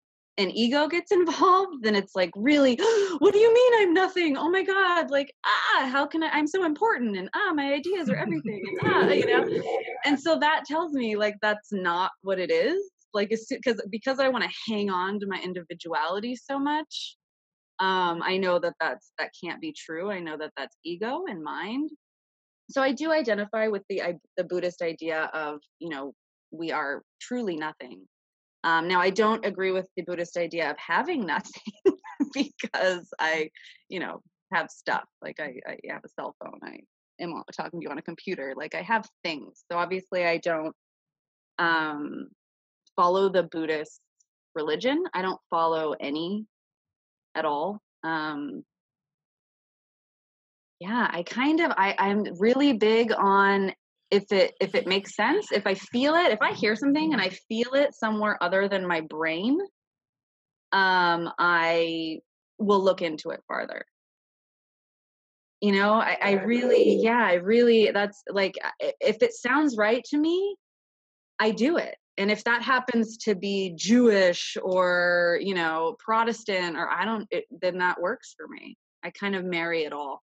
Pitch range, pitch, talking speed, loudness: 180-280 Hz, 210 Hz, 170 wpm, -25 LUFS